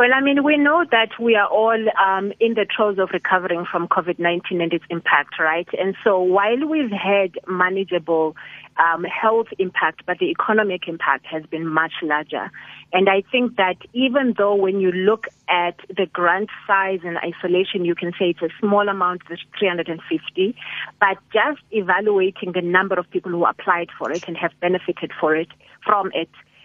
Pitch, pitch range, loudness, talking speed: 185 Hz, 175-205 Hz, -20 LUFS, 185 wpm